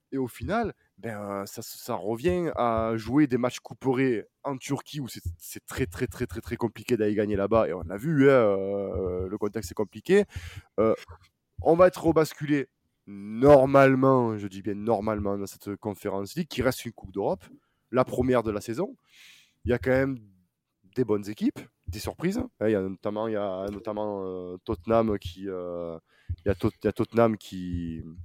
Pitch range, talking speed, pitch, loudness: 100-130 Hz, 195 wpm, 110 Hz, -27 LUFS